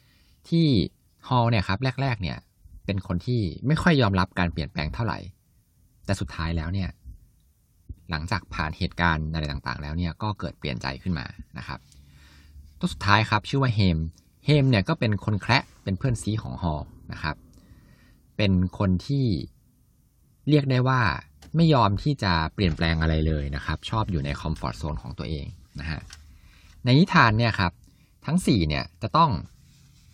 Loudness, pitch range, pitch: -25 LUFS, 80-115 Hz, 90 Hz